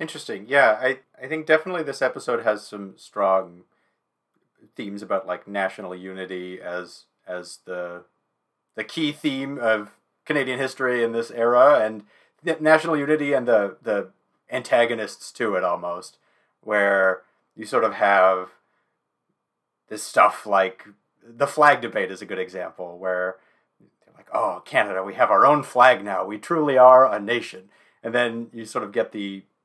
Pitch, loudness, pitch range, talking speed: 105 Hz, -21 LUFS, 95-130 Hz, 155 wpm